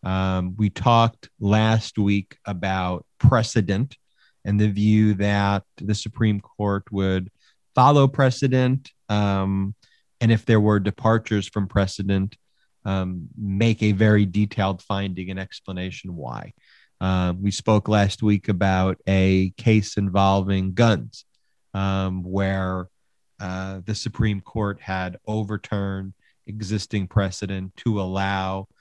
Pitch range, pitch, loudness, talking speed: 95-110 Hz, 100 Hz, -22 LUFS, 115 wpm